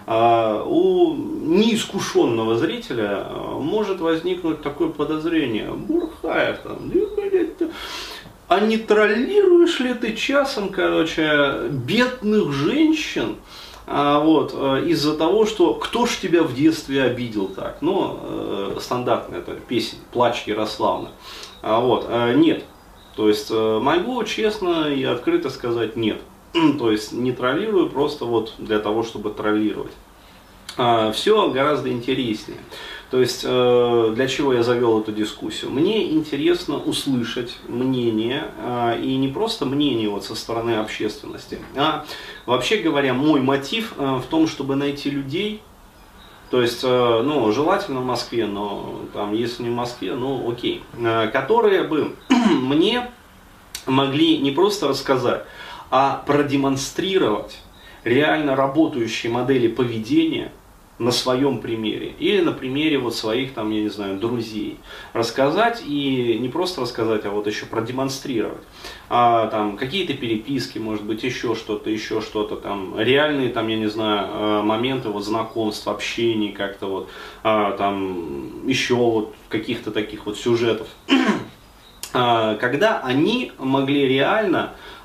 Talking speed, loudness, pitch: 120 wpm, -21 LUFS, 130 Hz